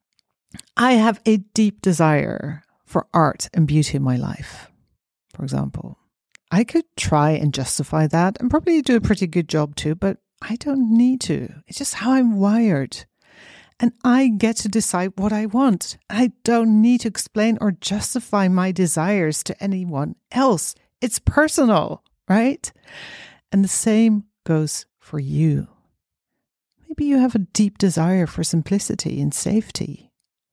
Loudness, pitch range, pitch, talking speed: -20 LUFS, 165-235 Hz, 205 Hz, 150 wpm